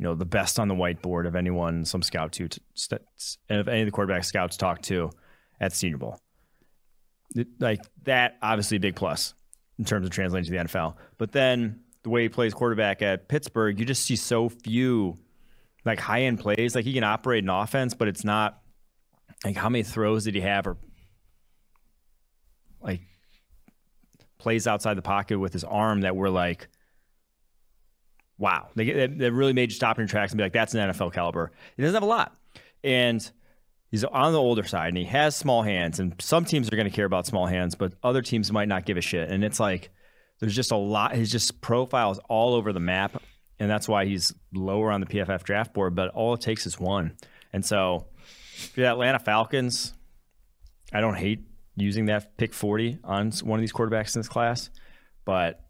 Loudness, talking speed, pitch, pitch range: -26 LUFS, 205 wpm, 105 Hz, 95-115 Hz